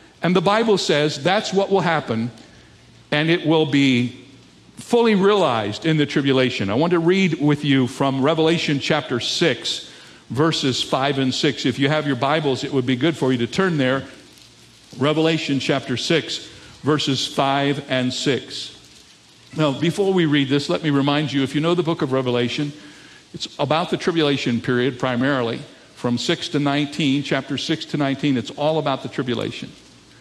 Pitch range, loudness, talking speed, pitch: 130-160 Hz, -20 LUFS, 175 wpm, 145 Hz